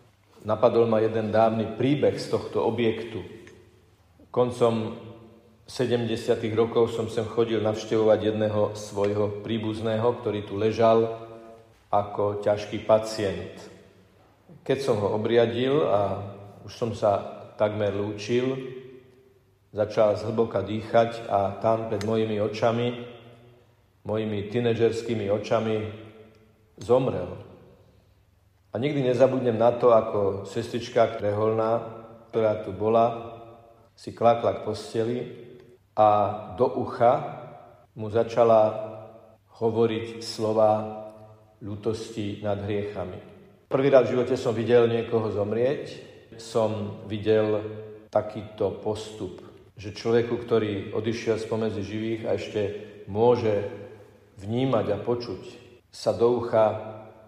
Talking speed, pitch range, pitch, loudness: 105 wpm, 105-115 Hz, 110 Hz, -25 LUFS